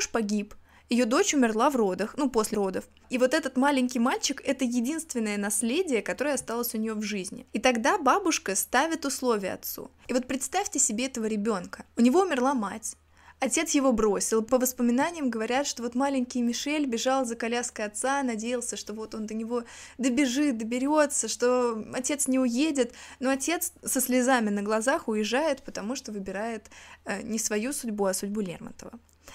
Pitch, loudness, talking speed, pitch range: 245 Hz, -27 LUFS, 165 wpm, 220-275 Hz